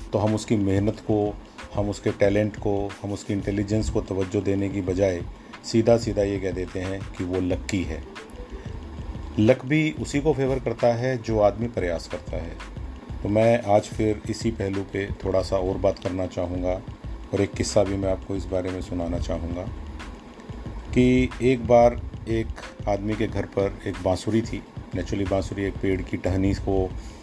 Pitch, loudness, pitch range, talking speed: 100 Hz, -25 LUFS, 95-110 Hz, 180 wpm